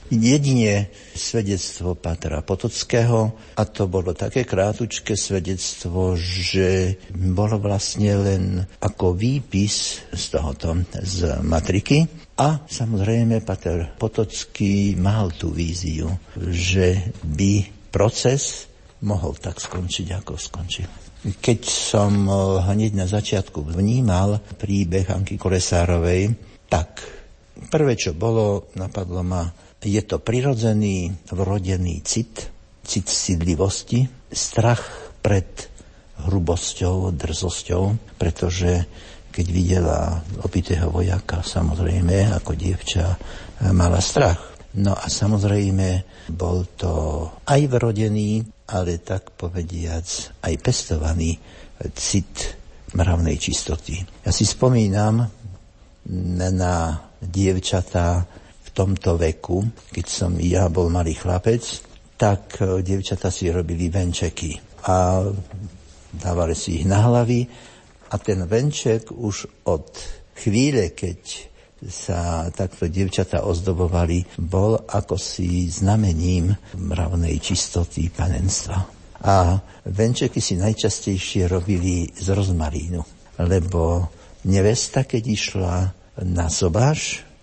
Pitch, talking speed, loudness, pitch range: 95 Hz, 95 wpm, -22 LUFS, 90-105 Hz